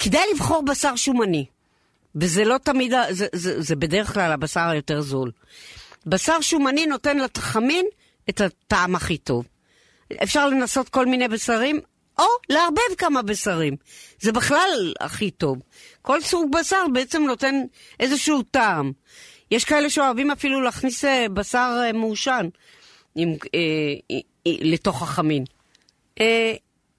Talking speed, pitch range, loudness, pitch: 125 wpm, 170-280 Hz, -21 LUFS, 240 Hz